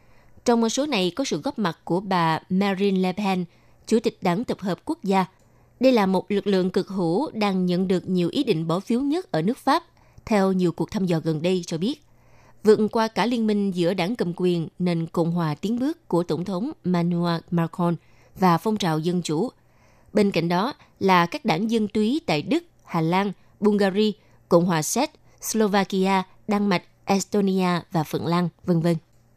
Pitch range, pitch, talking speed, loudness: 170-210 Hz, 185 Hz, 200 wpm, -23 LUFS